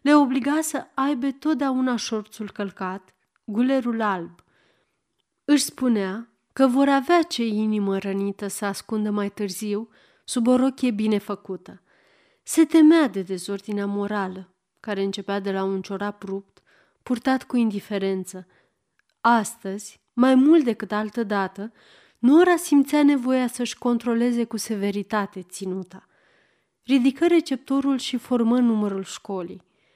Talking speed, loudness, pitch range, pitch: 120 wpm, -23 LUFS, 200-265 Hz, 220 Hz